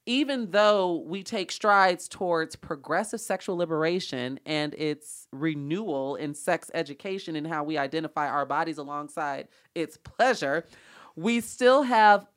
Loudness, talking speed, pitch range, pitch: -27 LUFS, 130 wpm, 150-200 Hz, 165 Hz